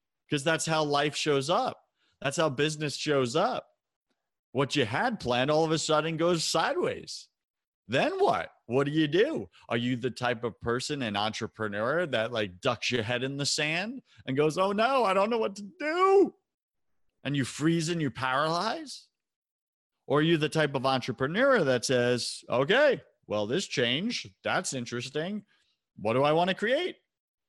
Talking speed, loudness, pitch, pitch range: 175 wpm, -28 LUFS, 150 Hz, 125-175 Hz